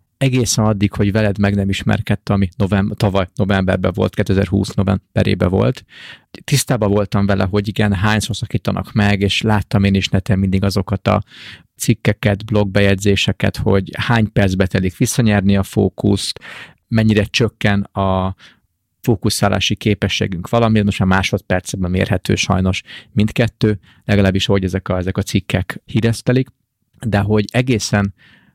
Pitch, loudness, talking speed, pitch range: 100 Hz, -17 LUFS, 135 wpm, 95-110 Hz